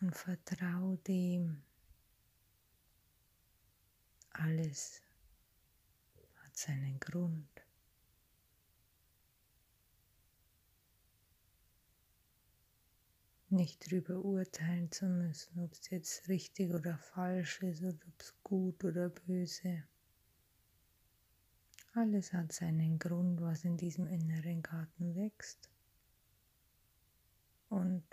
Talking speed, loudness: 75 wpm, -39 LUFS